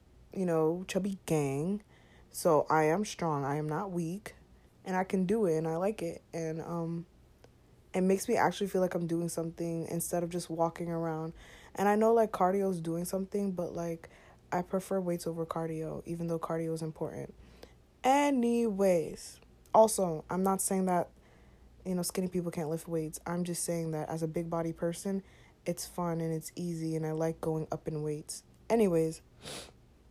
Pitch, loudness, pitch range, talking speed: 170 Hz, -32 LUFS, 160-190 Hz, 185 wpm